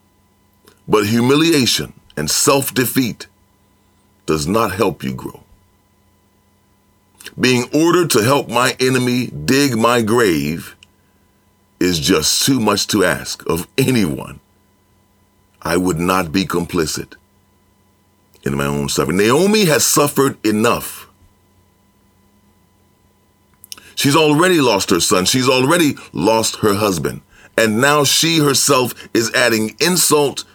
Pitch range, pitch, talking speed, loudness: 100-125 Hz, 100 Hz, 110 wpm, -15 LUFS